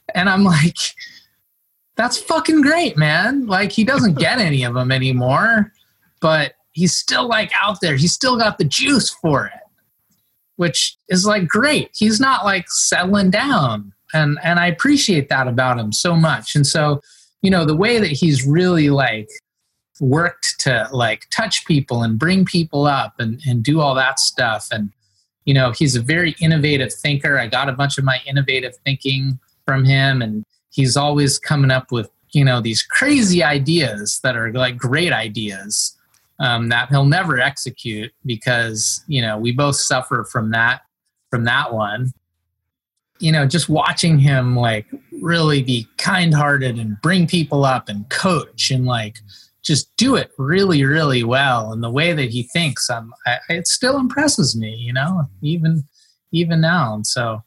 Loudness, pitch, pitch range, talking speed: -17 LUFS, 145 Hz, 125-175 Hz, 170 wpm